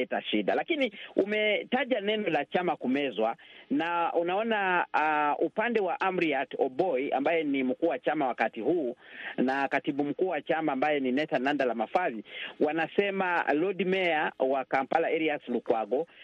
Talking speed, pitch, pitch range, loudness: 140 wpm, 165 Hz, 140-210 Hz, -29 LUFS